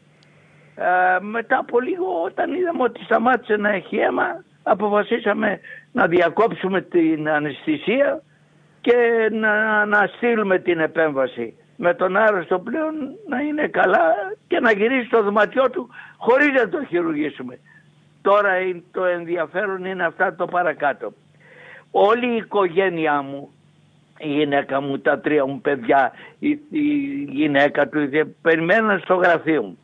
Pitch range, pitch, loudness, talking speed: 160-235 Hz, 190 Hz, -20 LUFS, 130 wpm